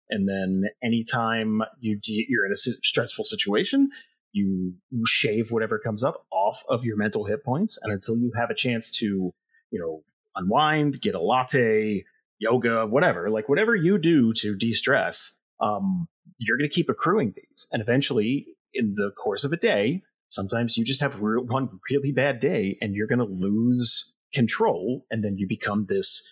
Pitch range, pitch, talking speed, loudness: 105-150 Hz, 115 Hz, 180 wpm, -25 LUFS